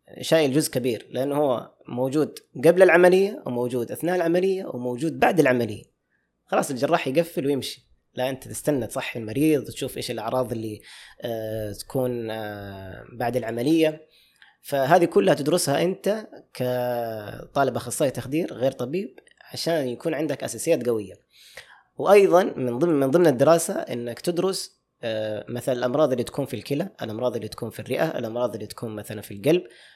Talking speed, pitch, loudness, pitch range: 145 wpm, 130 Hz, -24 LUFS, 120-165 Hz